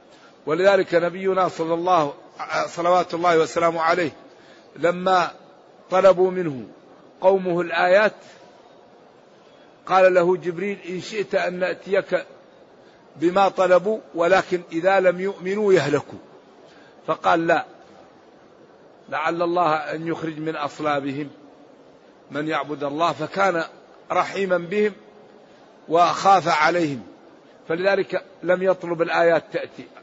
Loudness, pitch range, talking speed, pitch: -21 LUFS, 165-185 Hz, 95 wpm, 175 Hz